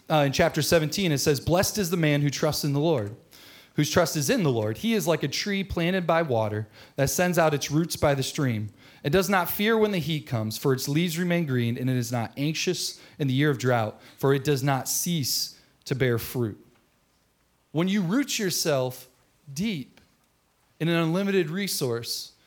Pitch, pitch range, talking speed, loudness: 150 Hz, 130-170 Hz, 205 wpm, -25 LUFS